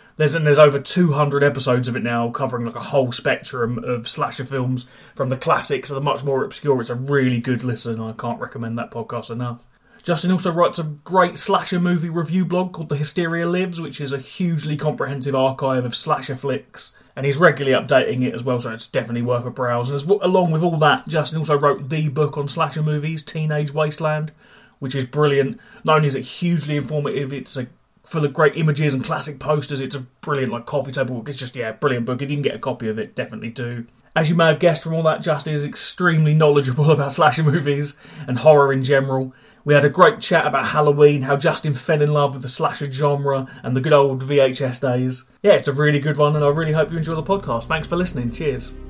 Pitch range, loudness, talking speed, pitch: 130-155 Hz, -20 LUFS, 230 wpm, 145 Hz